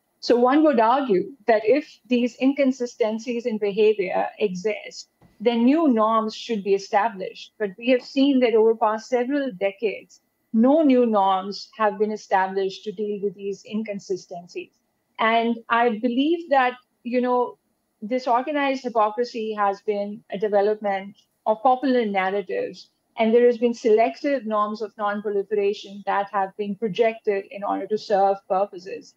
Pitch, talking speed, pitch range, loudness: 220 Hz, 145 wpm, 205-250 Hz, -22 LUFS